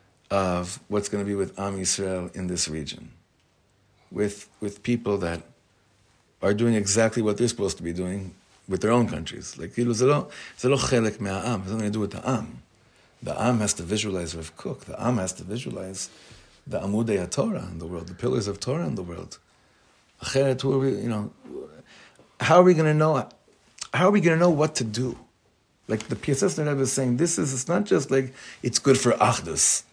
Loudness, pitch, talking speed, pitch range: -25 LUFS, 110 Hz, 185 wpm, 95-130 Hz